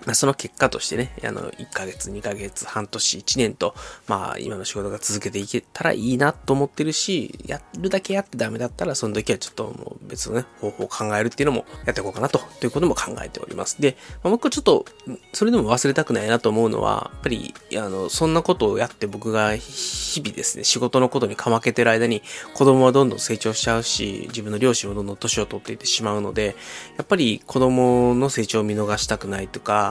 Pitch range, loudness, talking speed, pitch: 105-135 Hz, -22 LUFS, 425 characters per minute, 115 Hz